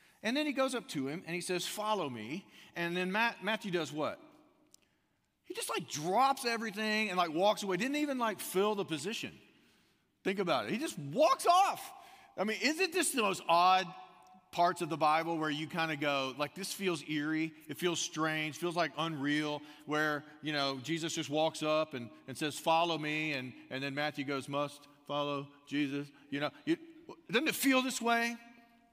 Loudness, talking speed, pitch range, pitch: -34 LUFS, 195 wpm, 150-235 Hz, 175 Hz